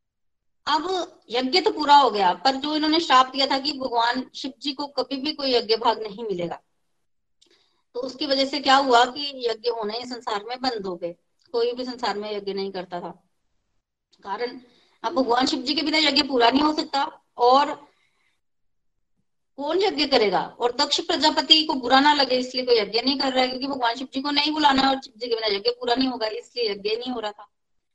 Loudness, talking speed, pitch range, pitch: -22 LUFS, 215 wpm, 235-290 Hz, 260 Hz